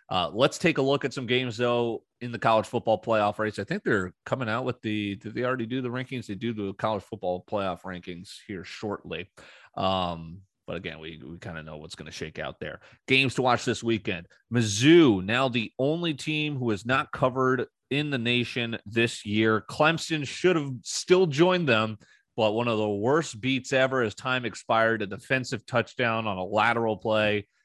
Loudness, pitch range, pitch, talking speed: -26 LUFS, 105-130 Hz, 115 Hz, 200 wpm